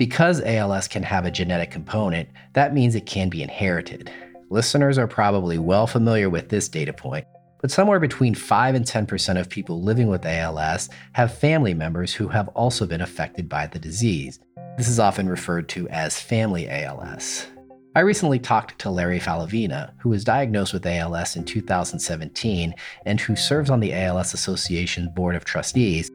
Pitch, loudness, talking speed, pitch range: 100 Hz, -22 LUFS, 170 wpm, 85-120 Hz